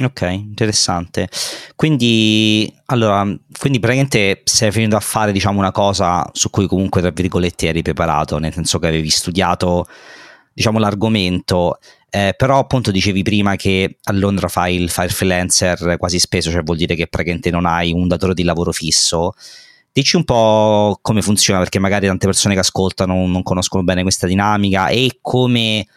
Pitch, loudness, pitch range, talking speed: 95 Hz, -15 LUFS, 90-110 Hz, 165 wpm